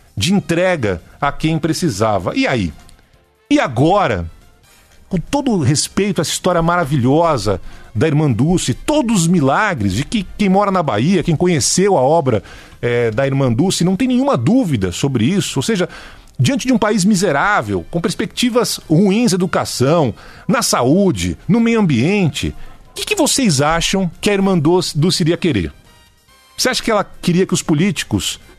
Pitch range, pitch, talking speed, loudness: 140-200 Hz, 175 Hz, 165 wpm, -15 LUFS